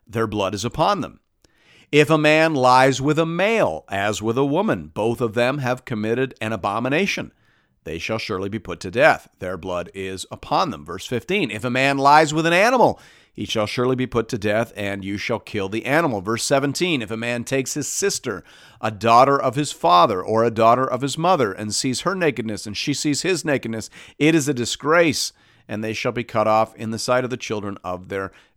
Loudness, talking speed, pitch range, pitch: -20 LUFS, 215 wpm, 105-140 Hz, 115 Hz